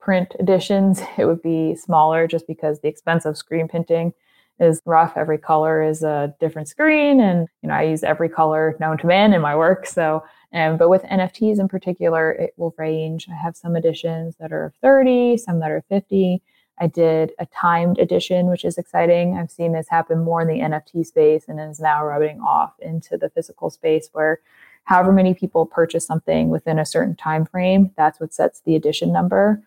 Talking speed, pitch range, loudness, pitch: 200 wpm, 155-180 Hz, -19 LUFS, 165 Hz